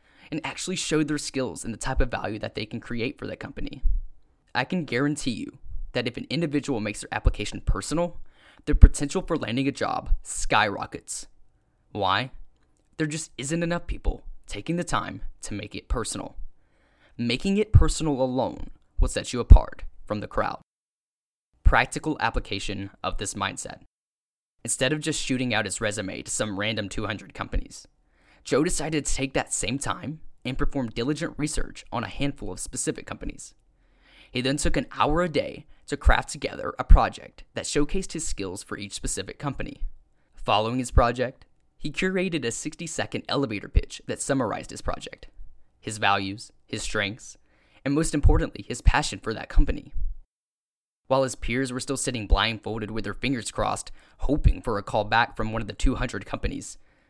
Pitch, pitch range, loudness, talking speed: 120 Hz, 105-150 Hz, -27 LUFS, 170 wpm